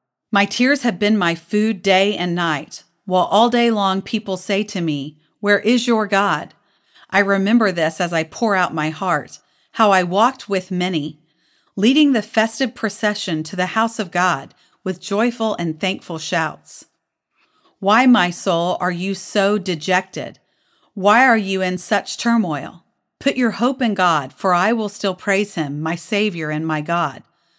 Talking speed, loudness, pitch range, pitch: 170 wpm, -18 LUFS, 170-220 Hz, 195 Hz